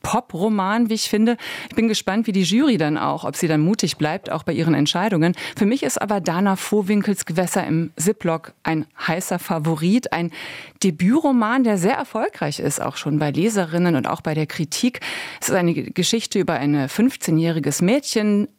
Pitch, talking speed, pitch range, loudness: 190 Hz, 180 wpm, 165-220 Hz, -20 LUFS